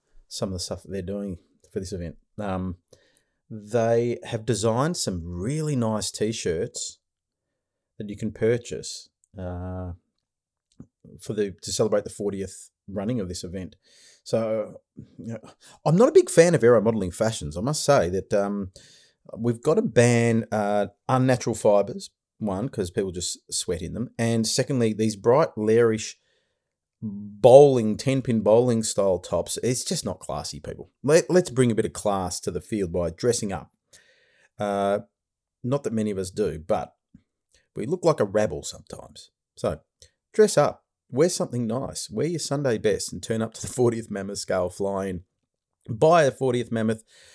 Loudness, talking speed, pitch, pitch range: -24 LUFS, 165 wpm, 110 Hz, 100-125 Hz